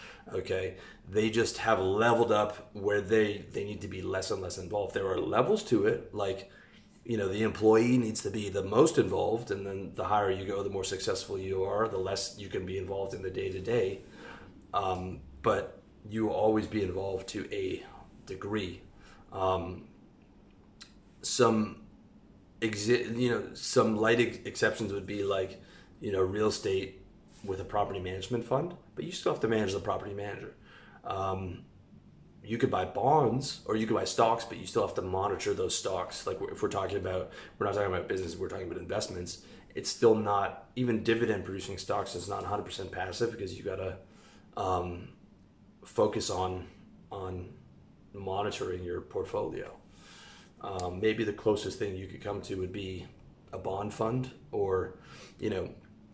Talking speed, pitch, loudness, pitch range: 175 wpm, 100 Hz, -32 LUFS, 95-115 Hz